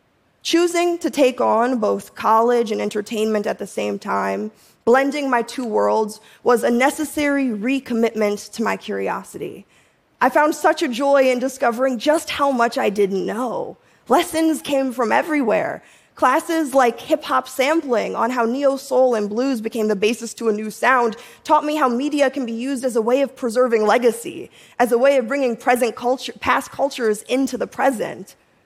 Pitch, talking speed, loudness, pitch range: 250 Hz, 175 wpm, -19 LUFS, 225-275 Hz